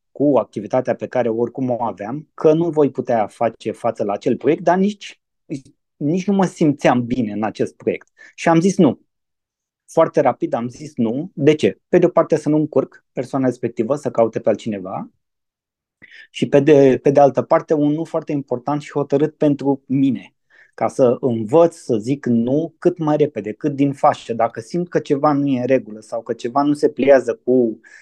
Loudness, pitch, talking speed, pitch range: -18 LUFS, 145 Hz, 195 wpm, 125-160 Hz